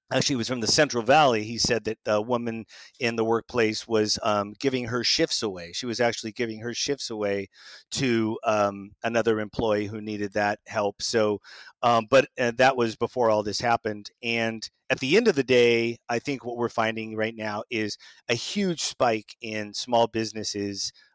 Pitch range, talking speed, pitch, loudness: 105-120 Hz, 185 wpm, 115 Hz, -25 LUFS